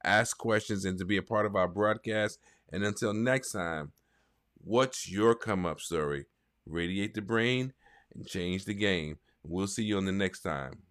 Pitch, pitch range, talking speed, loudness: 100 Hz, 90-105 Hz, 180 wpm, -31 LUFS